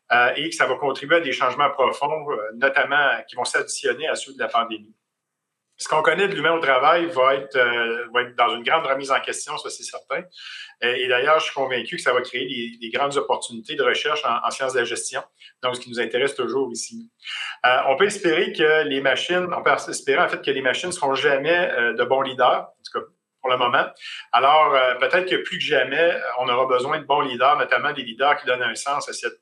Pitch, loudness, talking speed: 155 Hz, -21 LUFS, 230 wpm